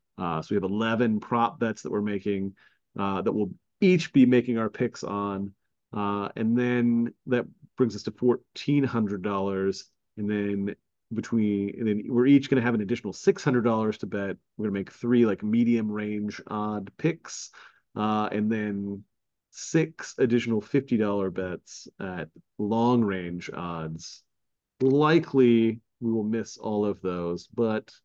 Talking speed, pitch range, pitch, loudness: 150 wpm, 100-120 Hz, 110 Hz, -27 LUFS